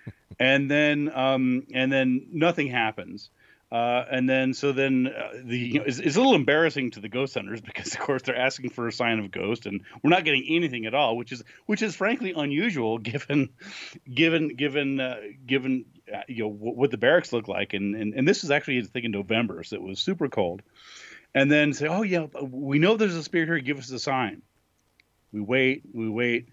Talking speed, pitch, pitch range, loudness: 215 wpm, 130 Hz, 115-145 Hz, -25 LUFS